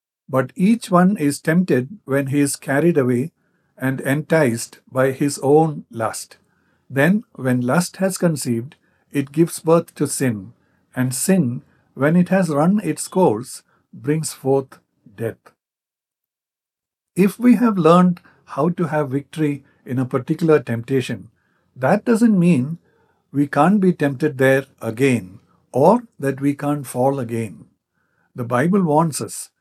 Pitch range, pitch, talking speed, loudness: 130-175 Hz, 145 Hz, 140 wpm, -19 LUFS